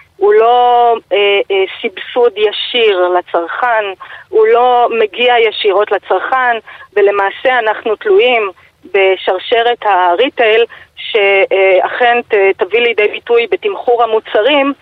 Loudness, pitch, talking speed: -11 LUFS, 240 Hz, 95 wpm